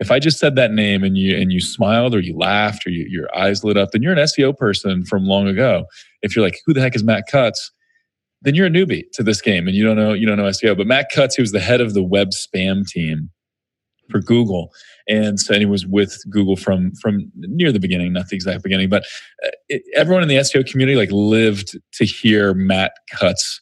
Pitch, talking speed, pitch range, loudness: 105 Hz, 240 wpm, 95-130 Hz, -17 LUFS